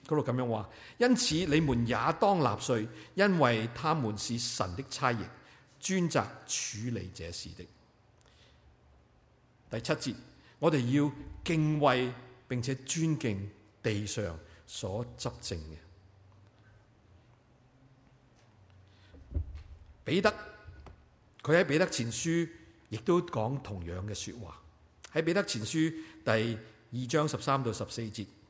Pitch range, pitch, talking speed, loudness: 100-145 Hz, 120 Hz, 160 characters per minute, -32 LUFS